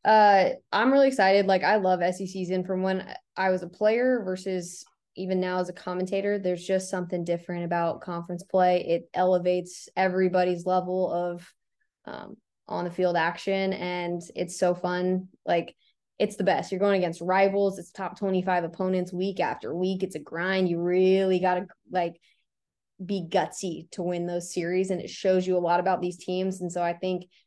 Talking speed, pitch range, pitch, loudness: 180 wpm, 180-190 Hz, 185 Hz, -26 LUFS